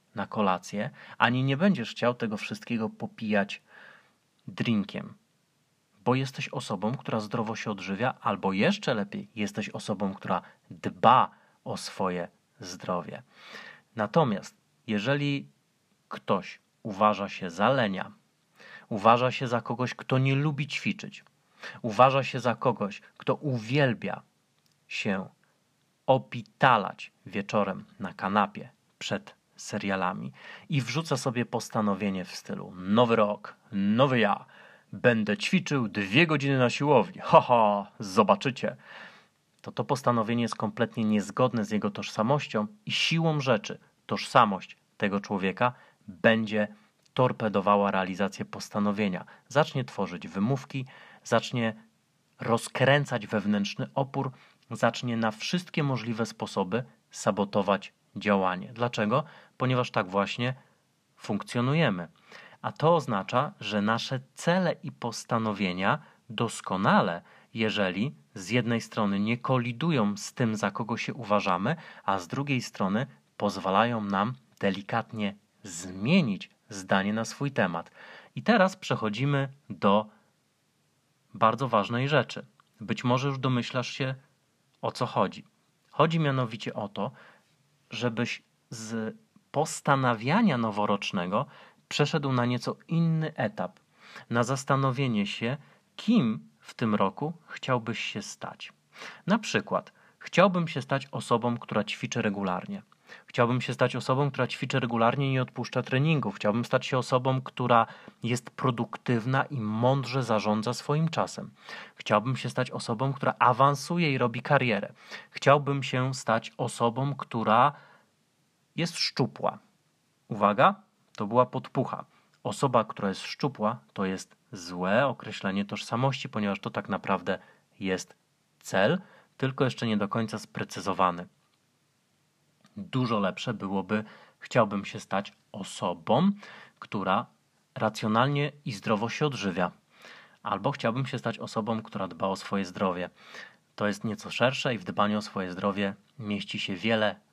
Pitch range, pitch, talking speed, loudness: 105-135 Hz, 120 Hz, 120 wpm, -28 LUFS